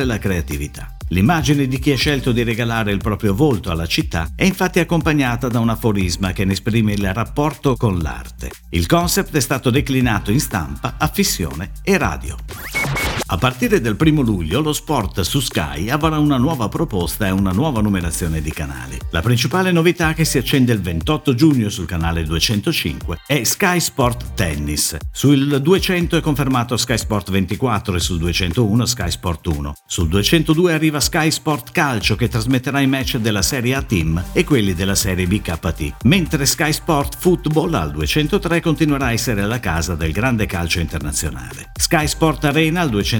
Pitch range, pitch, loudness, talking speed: 95-150 Hz, 120 Hz, -18 LUFS, 170 wpm